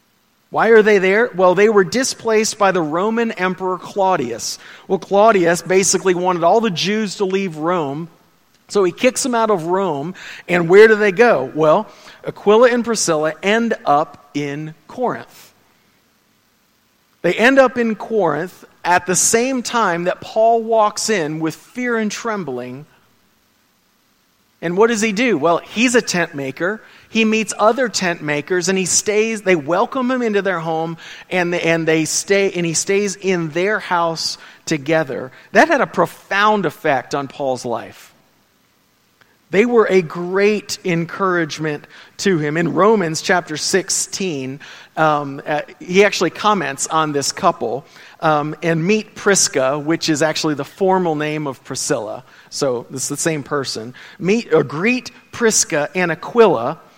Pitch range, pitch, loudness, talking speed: 160-215 Hz, 185 Hz, -17 LUFS, 155 wpm